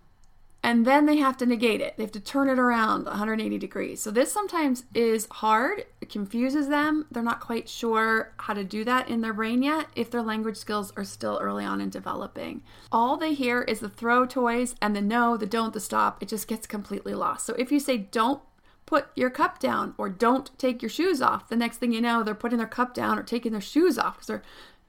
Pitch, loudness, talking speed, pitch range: 235 Hz, -26 LUFS, 230 wpm, 220-265 Hz